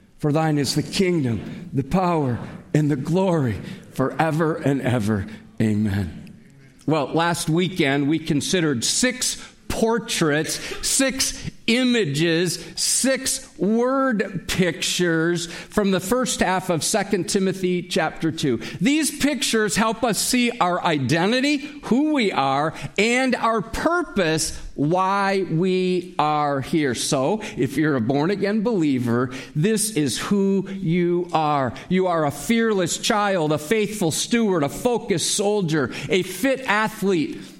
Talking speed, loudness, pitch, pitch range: 125 wpm, -21 LUFS, 180 Hz, 150-215 Hz